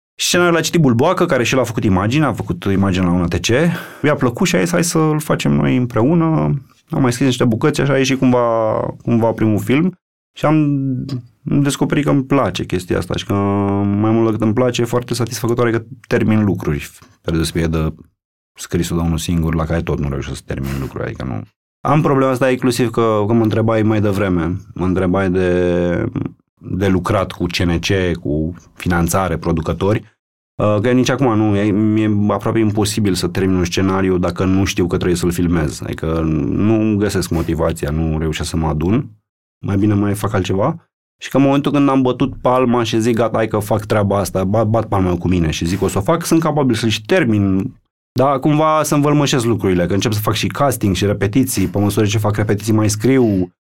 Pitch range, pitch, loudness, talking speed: 90-125 Hz, 105 Hz, -16 LUFS, 200 wpm